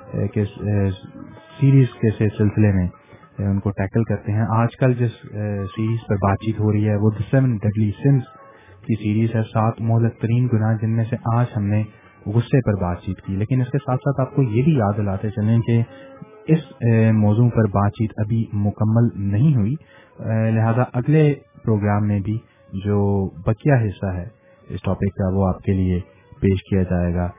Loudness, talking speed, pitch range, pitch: -20 LUFS, 175 wpm, 100-120 Hz, 110 Hz